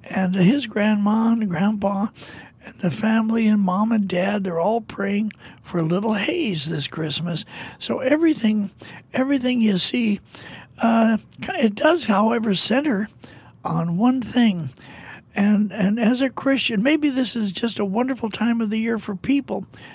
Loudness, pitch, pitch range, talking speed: -21 LUFS, 215 Hz, 190-235 Hz, 145 wpm